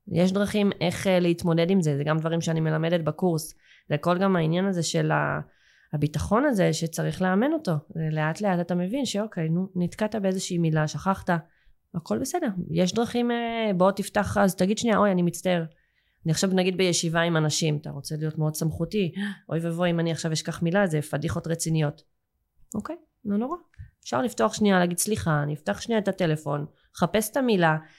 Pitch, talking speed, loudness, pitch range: 175 Hz, 175 wpm, -25 LUFS, 160-200 Hz